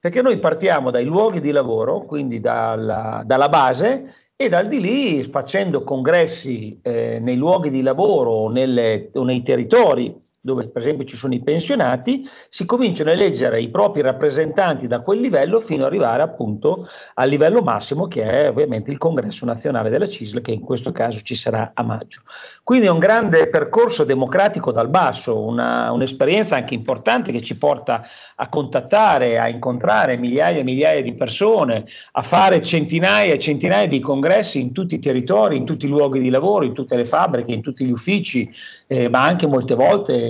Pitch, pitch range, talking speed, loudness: 145 Hz, 125-195 Hz, 180 wpm, -18 LUFS